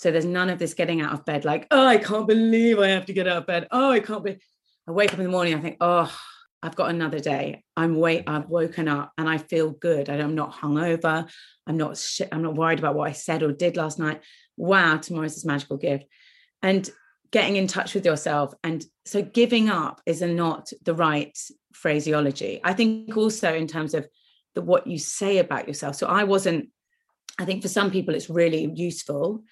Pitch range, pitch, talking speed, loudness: 155-195 Hz, 170 Hz, 220 wpm, -24 LUFS